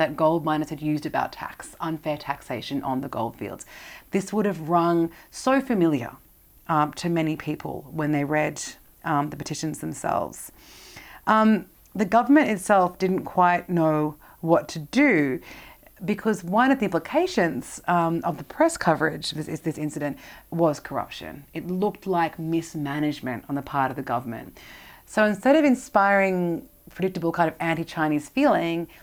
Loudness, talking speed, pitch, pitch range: -24 LUFS, 155 wpm, 165 Hz, 150-195 Hz